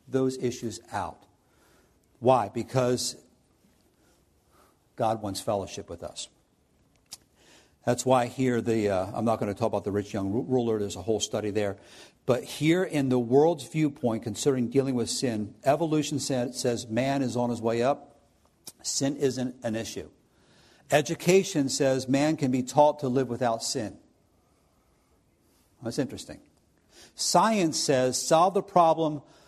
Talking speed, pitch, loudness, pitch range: 140 wpm, 125 Hz, -27 LUFS, 115-145 Hz